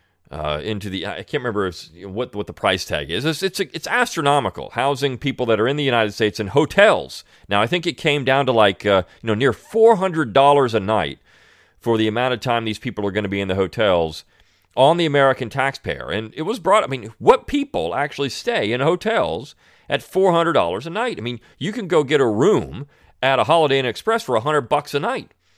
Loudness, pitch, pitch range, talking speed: -19 LUFS, 130 Hz, 105-160 Hz, 230 wpm